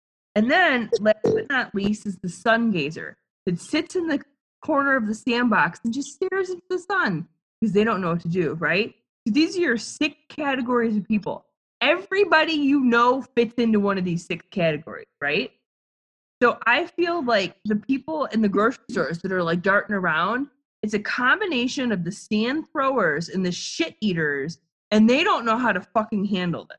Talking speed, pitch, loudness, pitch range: 190 wpm, 225 Hz, -23 LUFS, 200-285 Hz